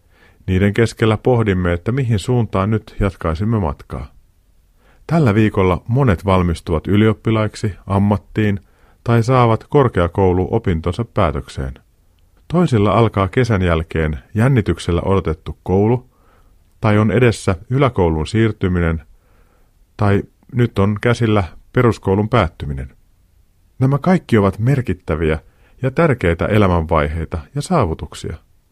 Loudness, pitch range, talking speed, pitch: -17 LUFS, 85-115 Hz, 95 wpm, 95 Hz